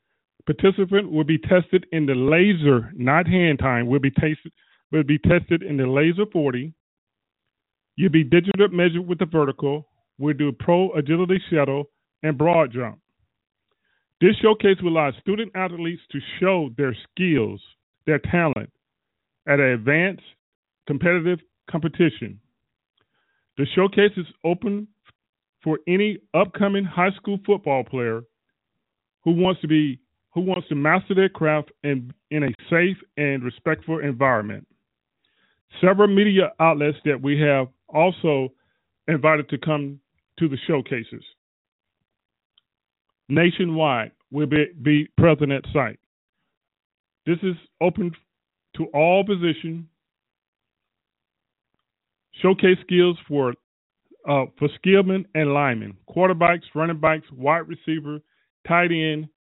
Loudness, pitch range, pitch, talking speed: -21 LUFS, 145-180 Hz, 160 Hz, 120 wpm